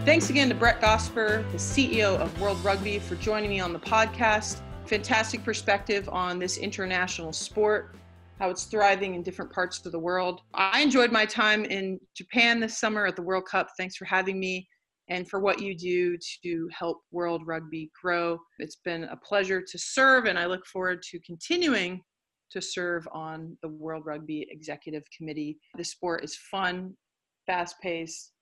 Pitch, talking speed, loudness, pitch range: 180 Hz, 175 wpm, -27 LUFS, 170-200 Hz